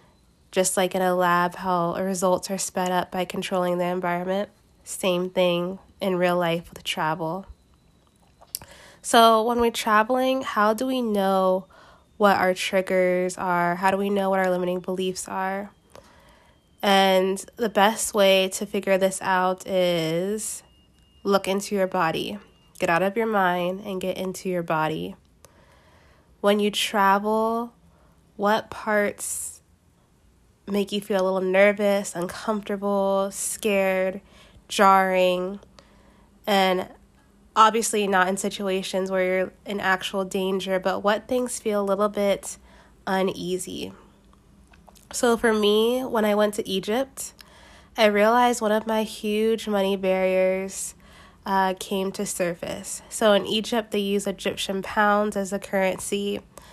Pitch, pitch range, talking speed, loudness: 195 Hz, 185-205 Hz, 135 wpm, -23 LUFS